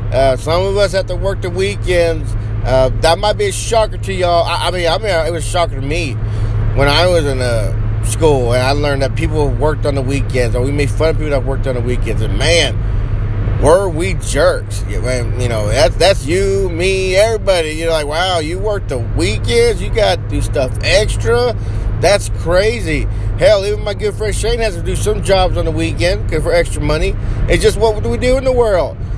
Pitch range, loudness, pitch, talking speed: 105-135 Hz, -15 LUFS, 110 Hz, 220 wpm